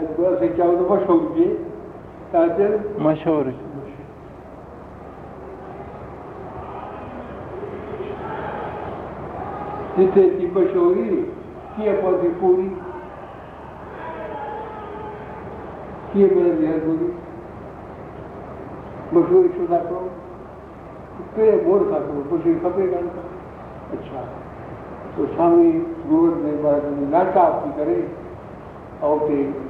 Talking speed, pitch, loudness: 85 wpm, 190 Hz, -20 LUFS